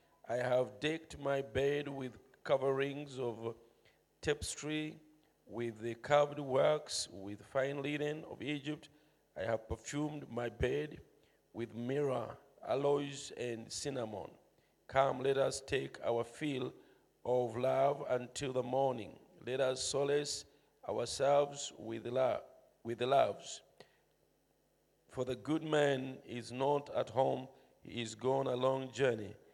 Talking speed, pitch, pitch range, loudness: 130 wpm, 135 Hz, 120-145 Hz, -37 LUFS